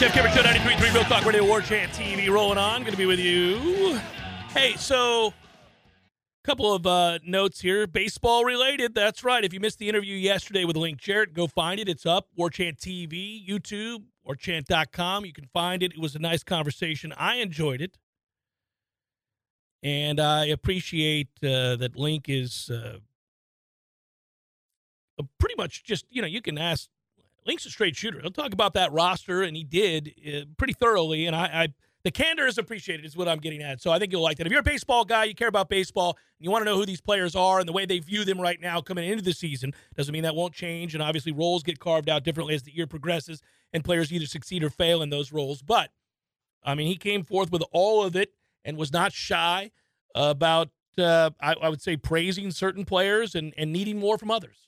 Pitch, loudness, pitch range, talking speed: 175 Hz, -25 LUFS, 160-200 Hz, 215 wpm